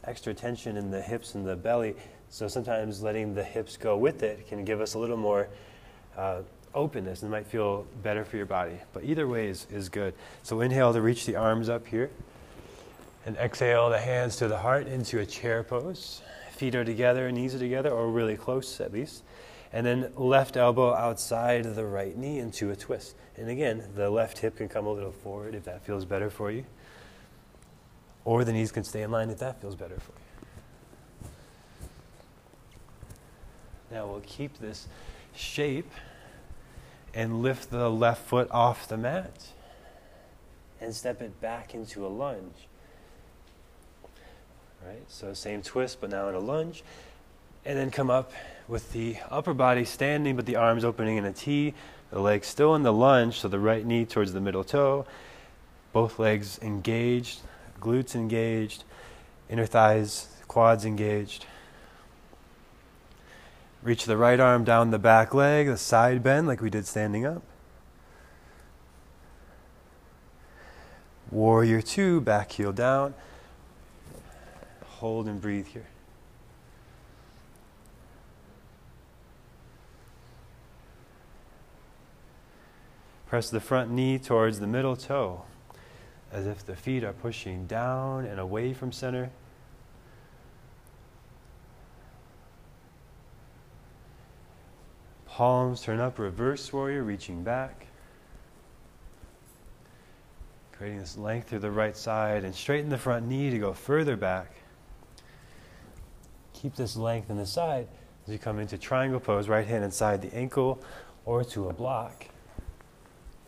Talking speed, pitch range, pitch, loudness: 140 wpm, 100-125 Hz, 115 Hz, -28 LUFS